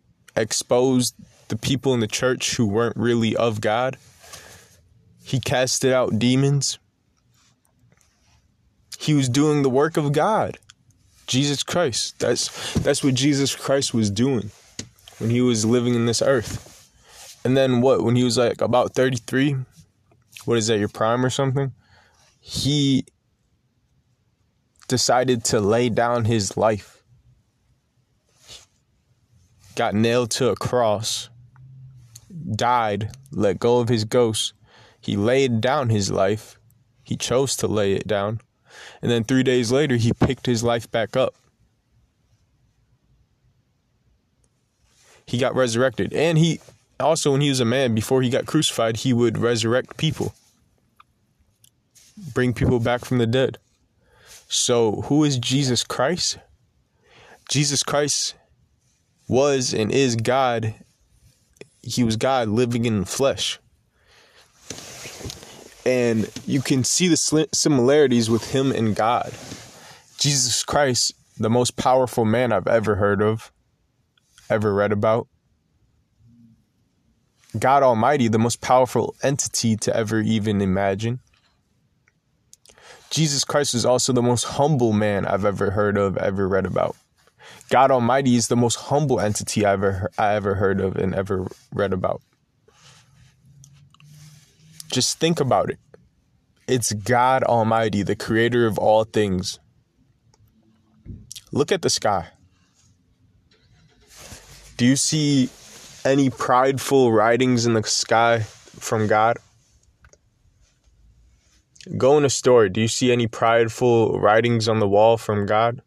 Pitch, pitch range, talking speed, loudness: 120 Hz, 110-130 Hz, 125 wpm, -20 LUFS